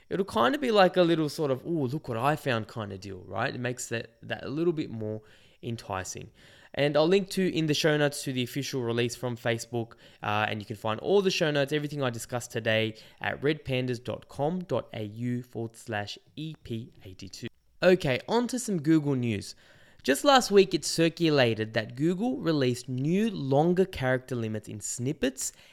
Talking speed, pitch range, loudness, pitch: 185 wpm, 115-160 Hz, -28 LUFS, 130 Hz